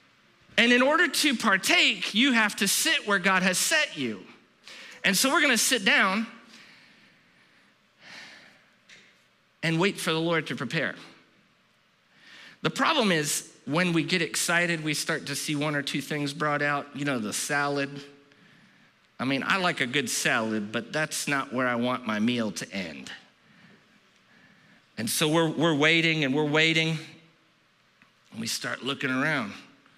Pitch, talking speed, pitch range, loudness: 160 Hz, 155 wpm, 145-200 Hz, -25 LUFS